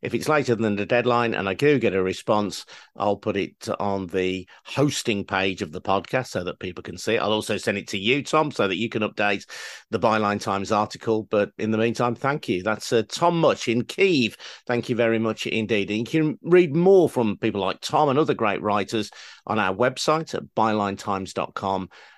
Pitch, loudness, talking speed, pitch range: 110 Hz, -23 LUFS, 215 wpm, 100-125 Hz